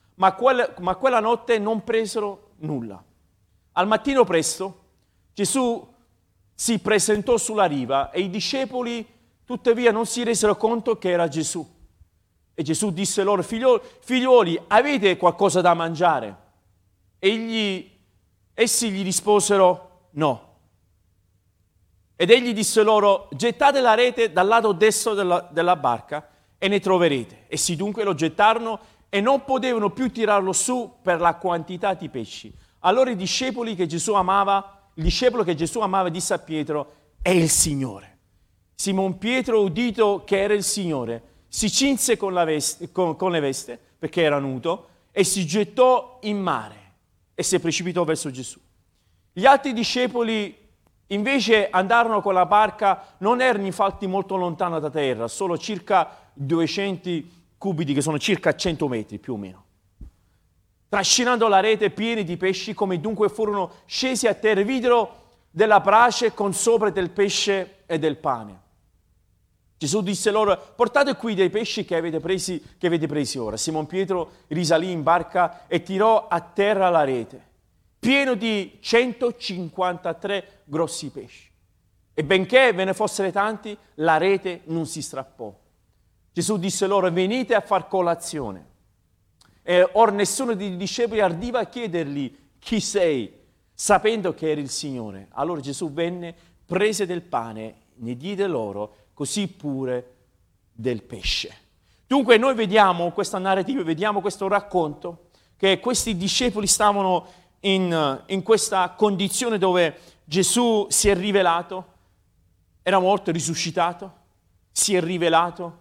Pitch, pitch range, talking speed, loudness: 185 Hz, 150-210 Hz, 140 wpm, -22 LUFS